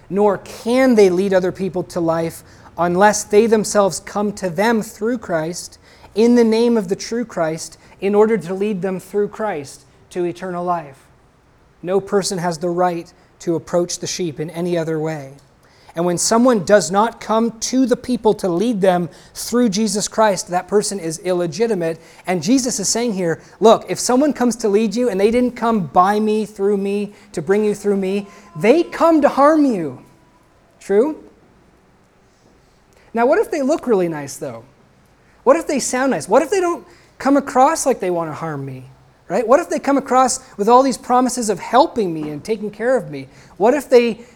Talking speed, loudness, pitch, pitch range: 190 wpm, -17 LUFS, 205 Hz, 175-235 Hz